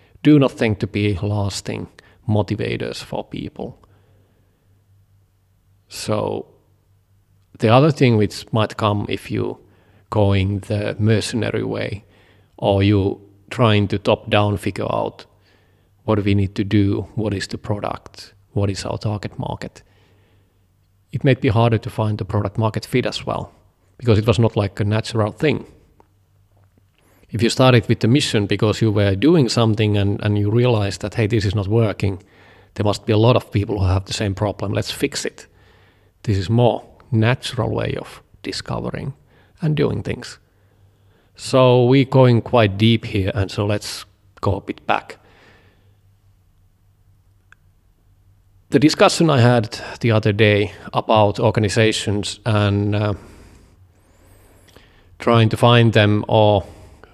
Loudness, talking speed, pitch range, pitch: -19 LUFS, 145 wpm, 100-110 Hz, 105 Hz